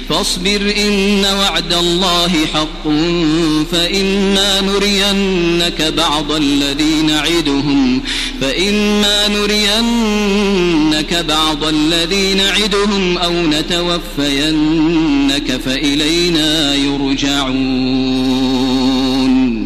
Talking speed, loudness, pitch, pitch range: 55 wpm, -13 LUFS, 170 Hz, 150-195 Hz